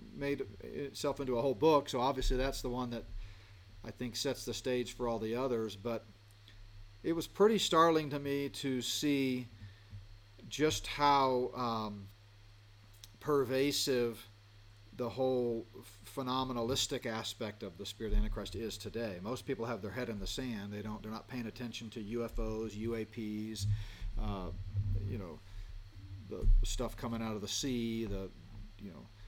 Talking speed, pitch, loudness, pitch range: 155 wpm, 110 Hz, -36 LUFS, 105-125 Hz